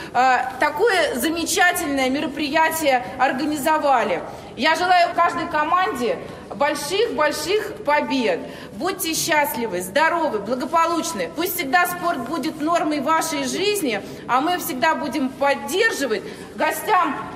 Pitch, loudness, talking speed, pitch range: 315 Hz, -20 LUFS, 95 wpm, 285-345 Hz